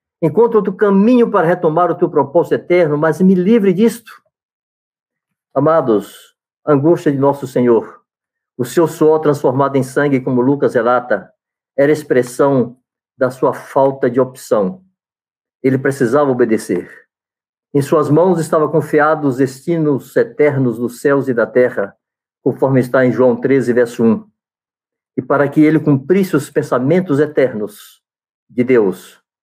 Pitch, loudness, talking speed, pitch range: 145 Hz, -14 LUFS, 140 wpm, 130-170 Hz